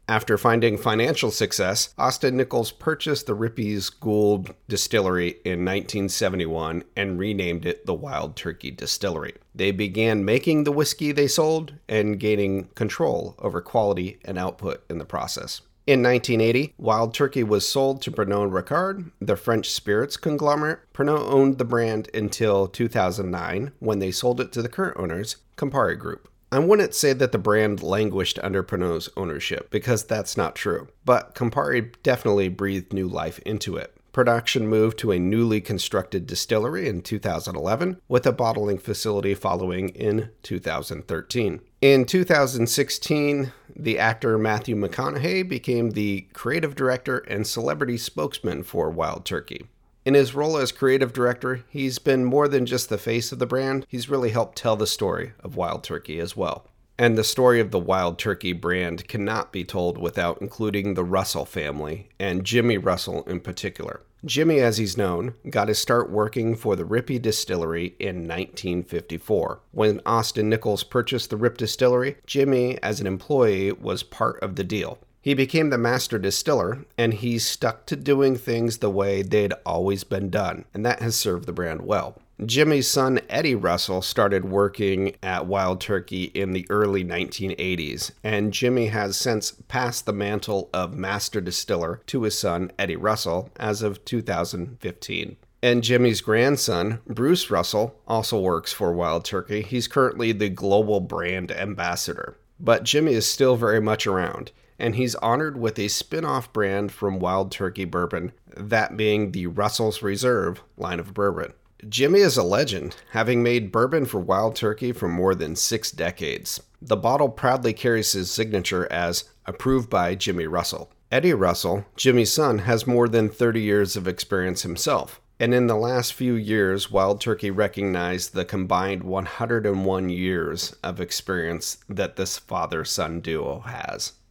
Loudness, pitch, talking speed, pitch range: -23 LUFS, 110 Hz, 160 wpm, 95-125 Hz